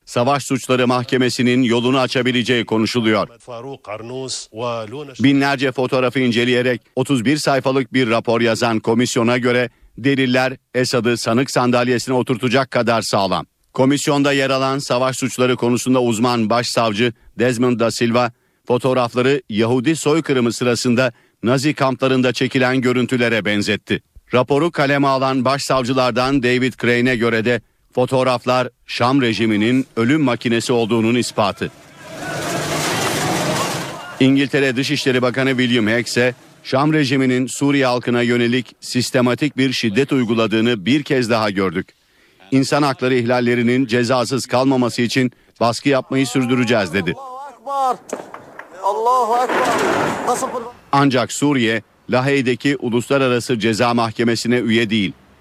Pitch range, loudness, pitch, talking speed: 120-135 Hz, -17 LUFS, 125 Hz, 105 wpm